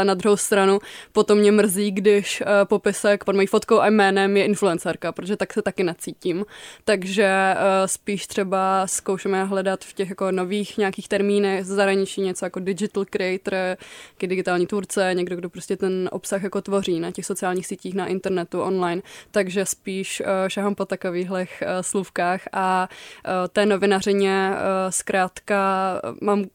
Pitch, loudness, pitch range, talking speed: 195 Hz, -22 LUFS, 185-200 Hz, 140 wpm